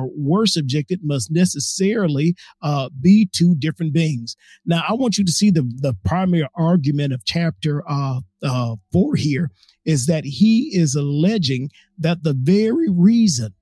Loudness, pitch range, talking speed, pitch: -19 LUFS, 140-180 Hz, 150 wpm, 160 Hz